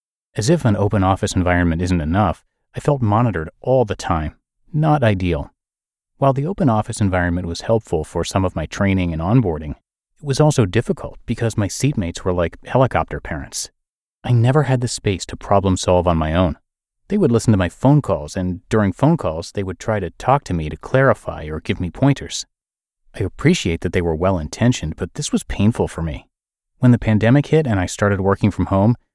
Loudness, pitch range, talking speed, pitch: -19 LUFS, 90-125 Hz, 205 wpm, 100 Hz